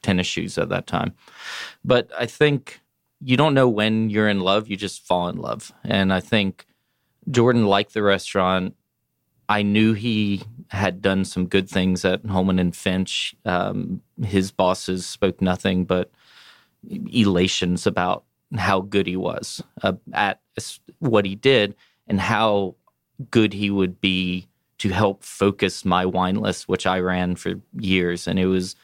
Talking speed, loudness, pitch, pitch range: 160 wpm, -22 LUFS, 95 Hz, 90-105 Hz